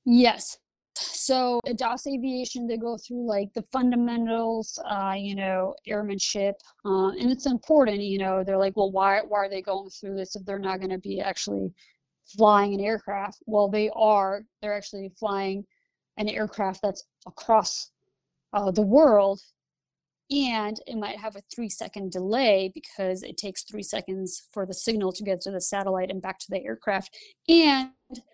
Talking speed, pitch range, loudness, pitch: 170 wpm, 195-230 Hz, -26 LUFS, 205 Hz